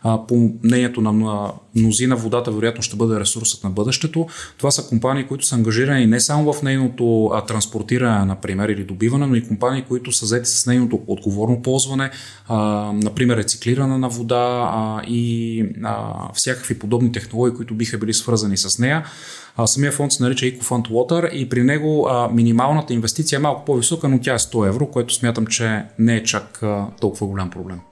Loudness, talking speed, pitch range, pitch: -19 LUFS, 165 wpm, 110-130 Hz, 120 Hz